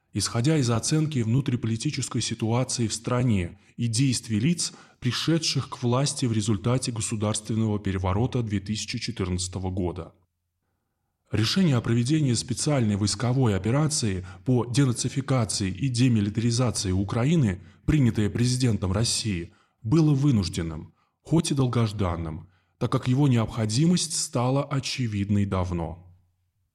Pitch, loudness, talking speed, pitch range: 115 Hz, -25 LUFS, 100 wpm, 100-130 Hz